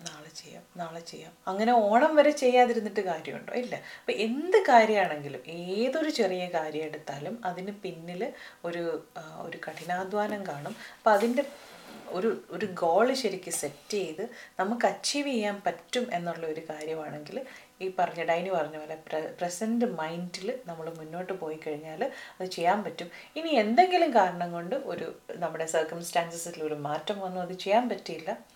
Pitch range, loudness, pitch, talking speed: 165-220 Hz, -29 LUFS, 180 Hz, 135 wpm